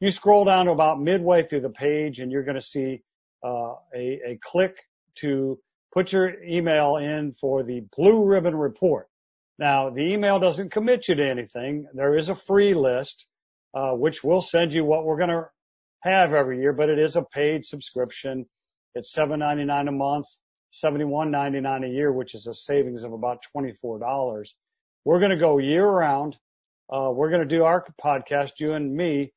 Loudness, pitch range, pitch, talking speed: -23 LUFS, 135-170 Hz, 145 Hz, 175 wpm